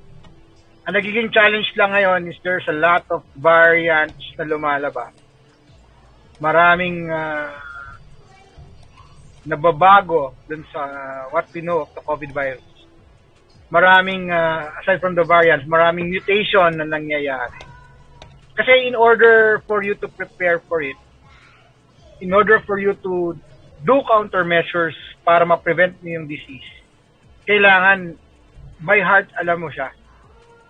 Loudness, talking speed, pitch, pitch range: -16 LUFS, 120 wpm, 170 Hz, 150-190 Hz